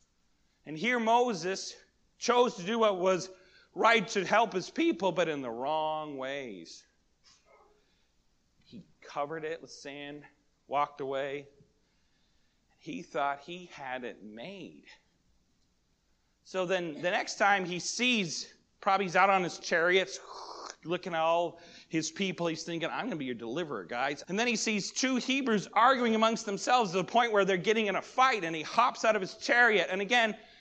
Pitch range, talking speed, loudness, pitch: 155-225 Hz, 170 wpm, -30 LUFS, 185 Hz